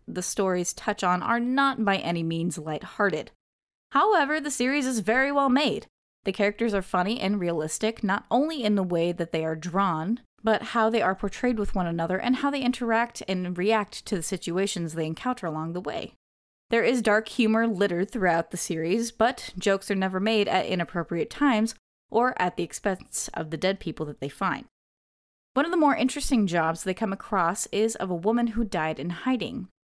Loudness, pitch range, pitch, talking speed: -26 LUFS, 175-235 Hz, 205 Hz, 195 wpm